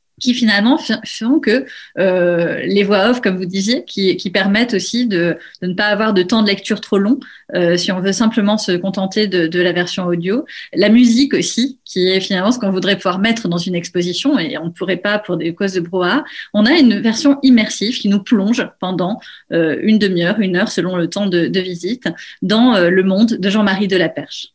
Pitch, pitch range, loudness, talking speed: 200 Hz, 180-225 Hz, -15 LUFS, 220 wpm